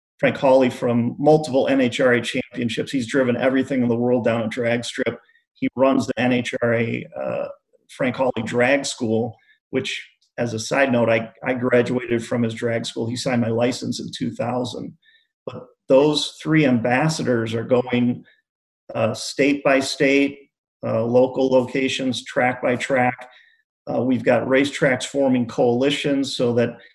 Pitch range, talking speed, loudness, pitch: 120-140 Hz, 150 wpm, -20 LUFS, 125 Hz